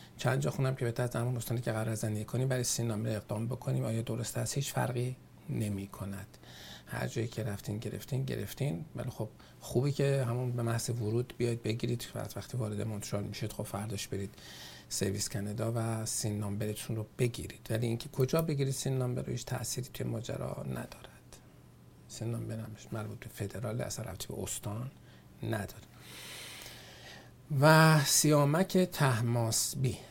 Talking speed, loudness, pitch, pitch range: 150 wpm, -33 LUFS, 115 Hz, 110-130 Hz